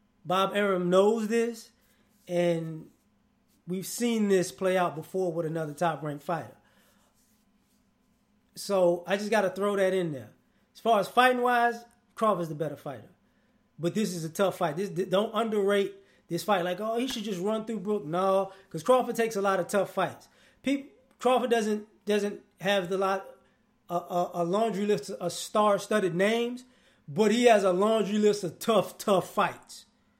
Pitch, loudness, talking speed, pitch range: 200 Hz, -28 LUFS, 175 wpm, 180-220 Hz